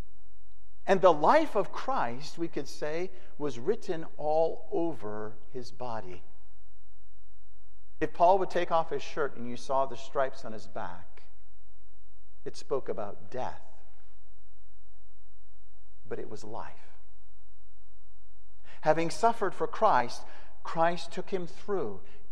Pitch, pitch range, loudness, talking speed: 120 Hz, 105-160 Hz, -31 LUFS, 120 wpm